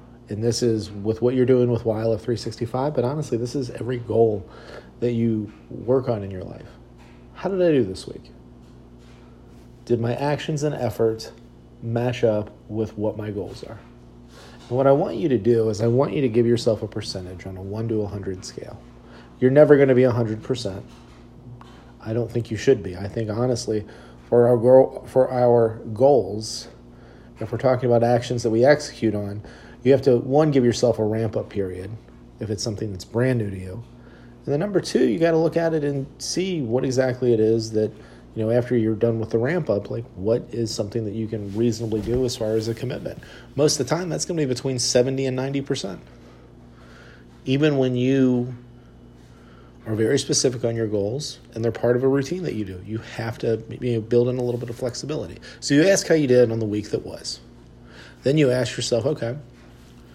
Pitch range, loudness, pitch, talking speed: 105-125 Hz, -22 LUFS, 115 Hz, 210 wpm